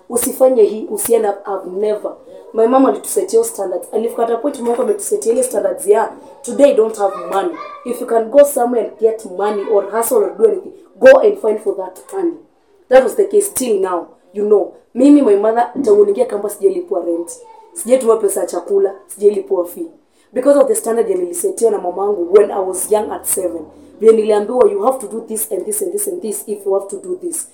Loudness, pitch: -15 LUFS, 260 Hz